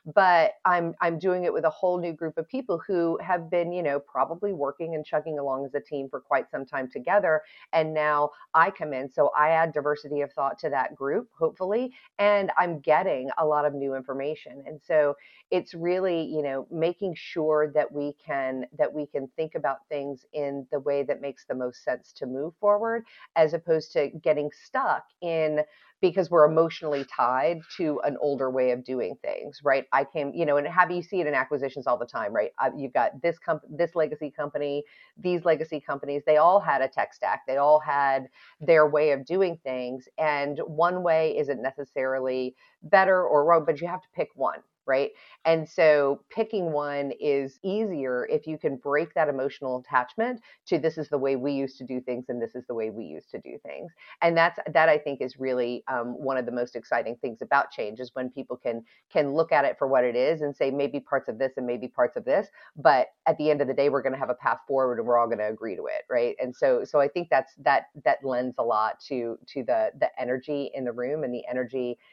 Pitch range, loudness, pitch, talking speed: 135-165 Hz, -26 LUFS, 150 Hz, 225 wpm